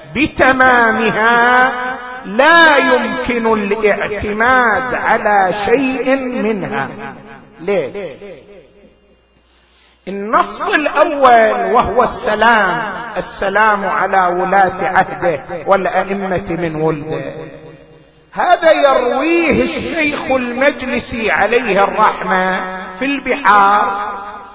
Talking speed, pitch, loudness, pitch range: 65 wpm, 215 Hz, -13 LUFS, 190-255 Hz